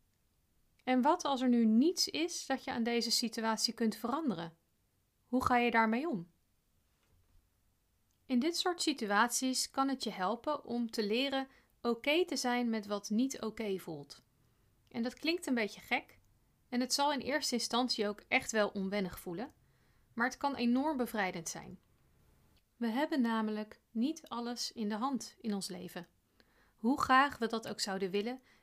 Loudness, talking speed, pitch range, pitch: -34 LUFS, 170 wpm, 200-260 Hz, 235 Hz